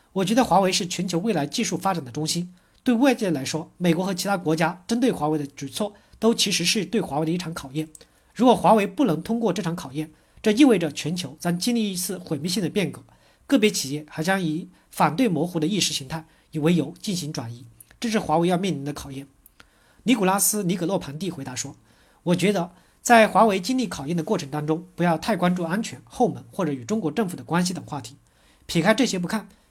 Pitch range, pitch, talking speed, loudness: 155-210 Hz, 175 Hz, 335 characters per minute, -23 LUFS